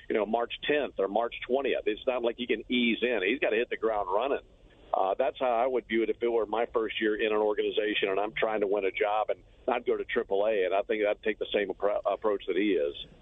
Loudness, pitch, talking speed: -29 LUFS, 390 Hz, 275 wpm